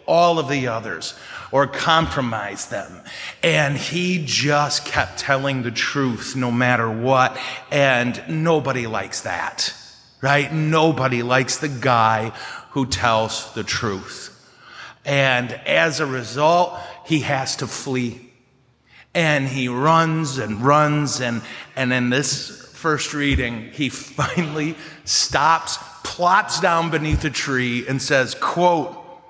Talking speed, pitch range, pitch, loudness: 125 wpm, 125-155 Hz, 140 Hz, -20 LUFS